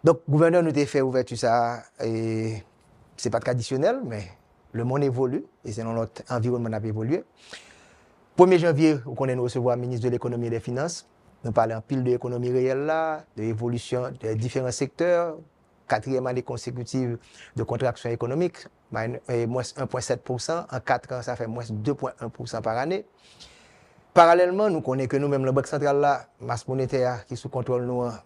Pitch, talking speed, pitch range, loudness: 125 Hz, 170 wpm, 115-140 Hz, -25 LUFS